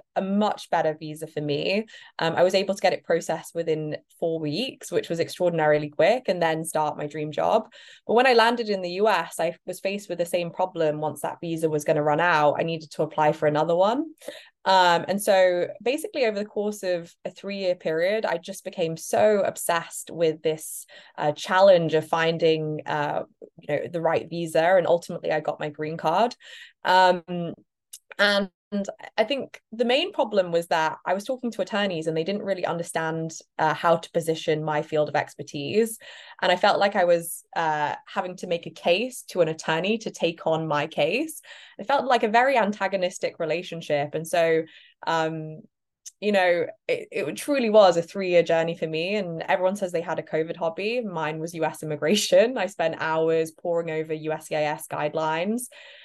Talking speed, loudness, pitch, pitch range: 195 wpm, -24 LUFS, 170 Hz, 160-200 Hz